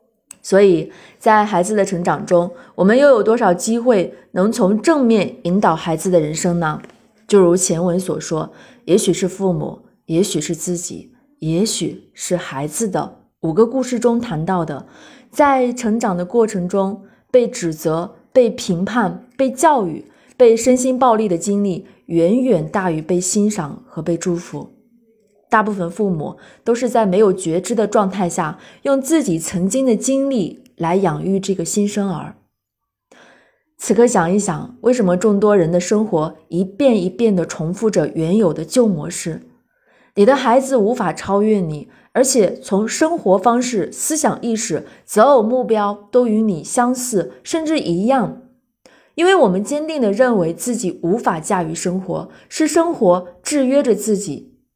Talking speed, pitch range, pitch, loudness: 230 characters per minute, 180-240 Hz, 205 Hz, -17 LUFS